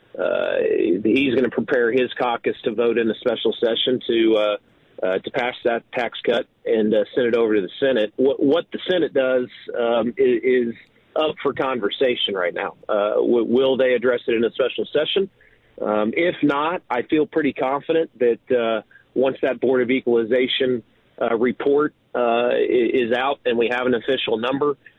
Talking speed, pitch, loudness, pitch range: 185 wpm, 130 Hz, -21 LUFS, 120-185 Hz